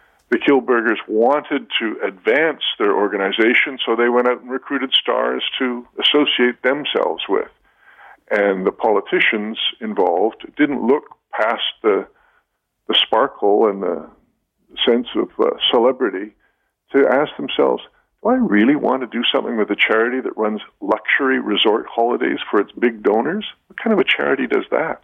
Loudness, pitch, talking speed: -18 LUFS, 130 Hz, 150 wpm